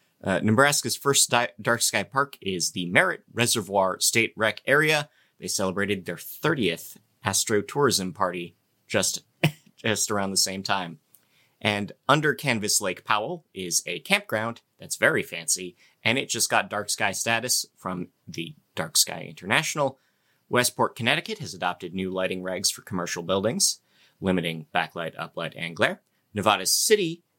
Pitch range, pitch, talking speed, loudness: 95-120 Hz, 105 Hz, 145 wpm, -24 LUFS